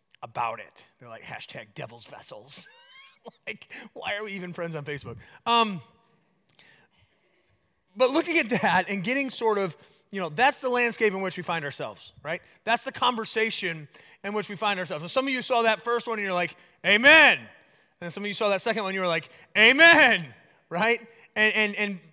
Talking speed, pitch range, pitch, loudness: 200 wpm, 180-235 Hz, 210 Hz, -23 LUFS